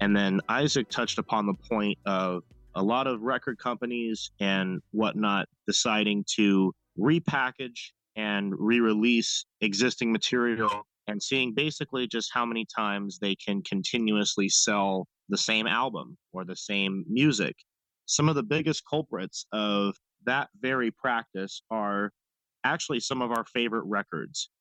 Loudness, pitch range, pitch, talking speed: -28 LUFS, 100-120 Hz, 110 Hz, 140 wpm